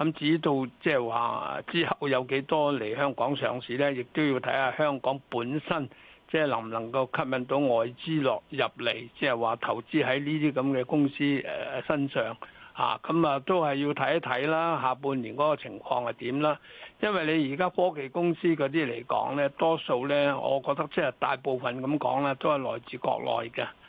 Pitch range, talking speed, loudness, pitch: 130-155 Hz, 280 characters per minute, -28 LUFS, 140 Hz